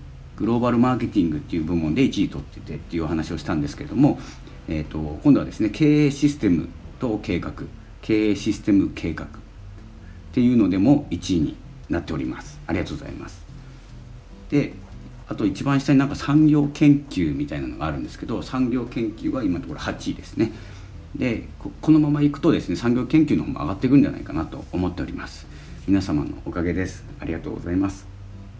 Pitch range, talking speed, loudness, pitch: 90-140 Hz, 395 characters per minute, -22 LUFS, 110 Hz